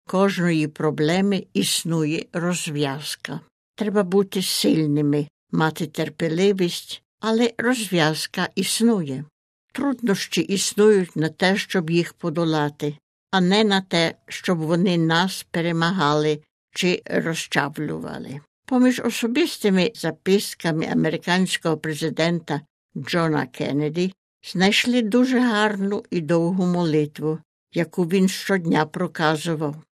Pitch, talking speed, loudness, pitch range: 175 Hz, 90 wpm, -22 LUFS, 155-195 Hz